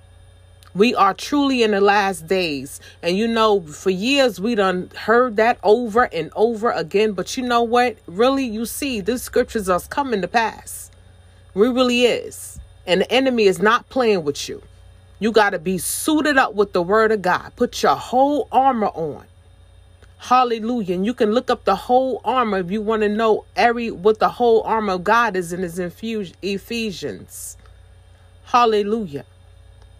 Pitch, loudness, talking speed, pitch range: 210 Hz, -19 LUFS, 170 wpm, 160-235 Hz